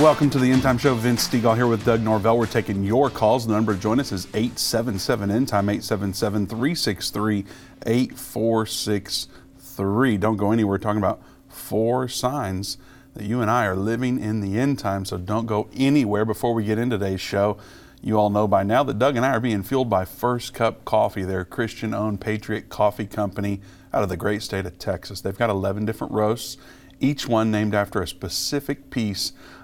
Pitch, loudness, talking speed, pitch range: 110 Hz, -23 LUFS, 190 wpm, 100-120 Hz